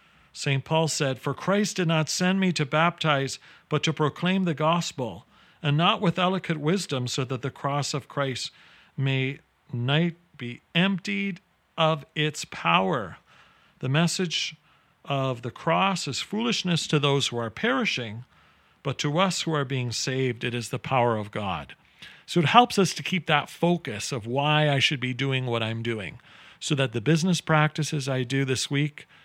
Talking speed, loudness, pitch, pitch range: 175 wpm, -25 LUFS, 150 Hz, 135-170 Hz